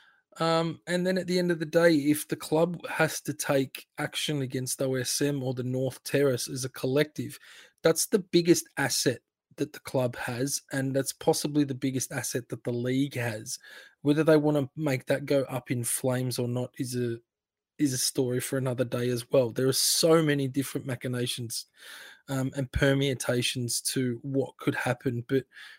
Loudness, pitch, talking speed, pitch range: -28 LUFS, 135 Hz, 185 wpm, 125-150 Hz